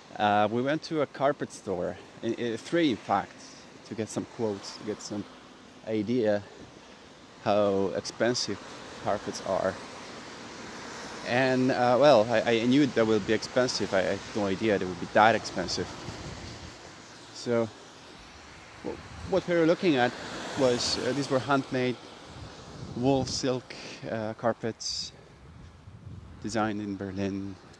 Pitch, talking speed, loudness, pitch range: 115 Hz, 135 wpm, -28 LUFS, 105-130 Hz